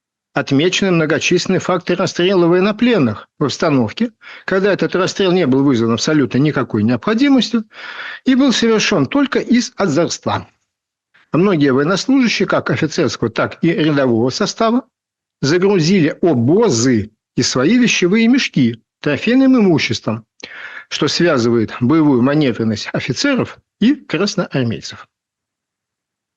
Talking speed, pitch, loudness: 100 wpm, 175 Hz, -15 LUFS